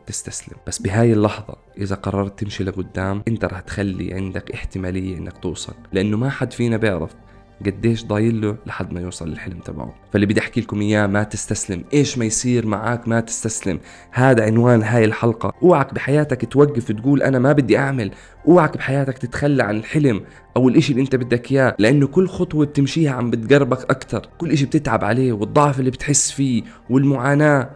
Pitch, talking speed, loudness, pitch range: 115 Hz, 175 wpm, -19 LUFS, 100-135 Hz